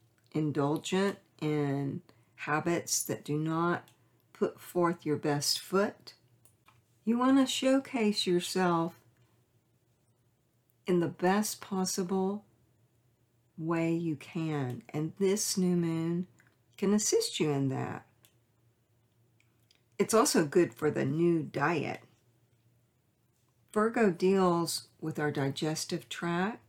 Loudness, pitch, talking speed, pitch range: -31 LUFS, 150 Hz, 100 wpm, 120-180 Hz